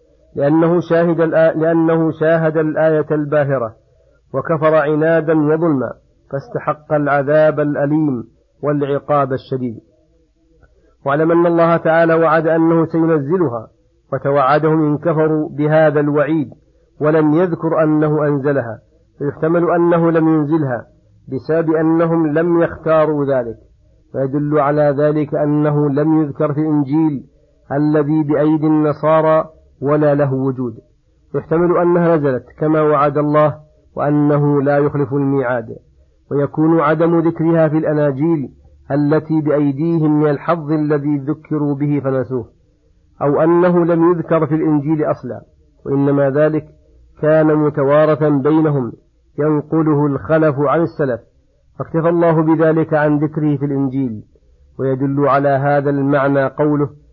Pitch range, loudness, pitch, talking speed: 145-160 Hz, -15 LUFS, 150 Hz, 110 wpm